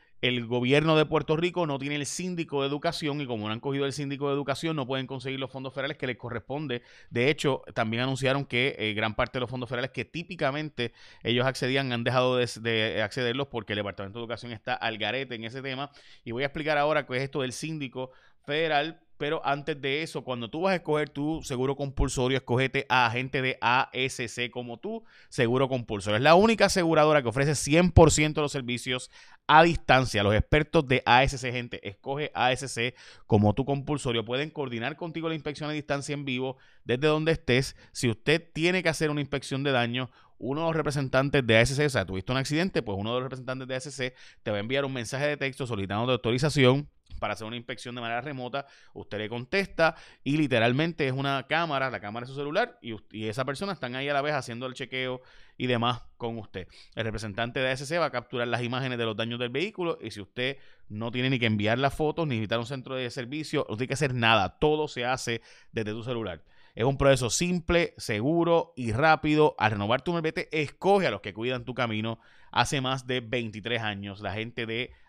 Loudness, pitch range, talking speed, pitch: -27 LUFS, 120-150 Hz, 215 wpm, 130 Hz